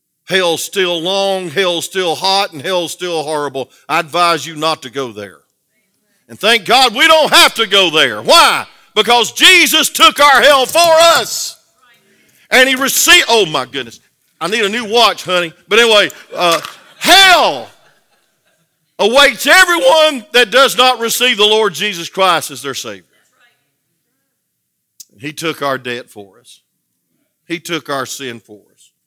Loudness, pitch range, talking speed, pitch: -10 LUFS, 160-260 Hz, 155 wpm, 195 Hz